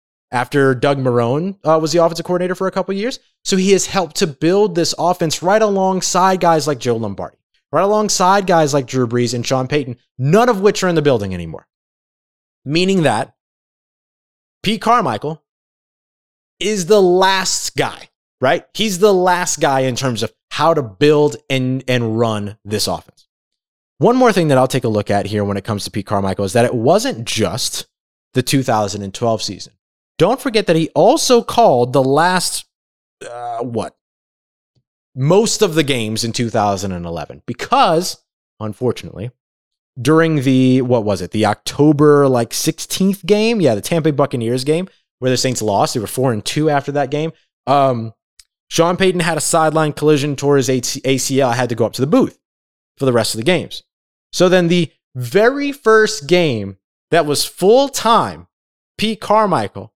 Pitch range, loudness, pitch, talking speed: 120-180 Hz, -16 LUFS, 145 Hz, 175 wpm